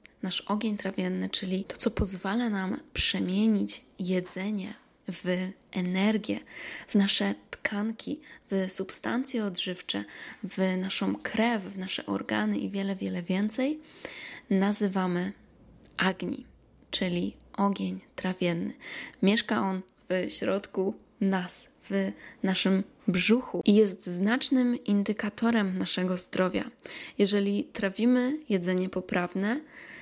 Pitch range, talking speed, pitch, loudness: 185-215 Hz, 100 wpm, 195 Hz, -29 LUFS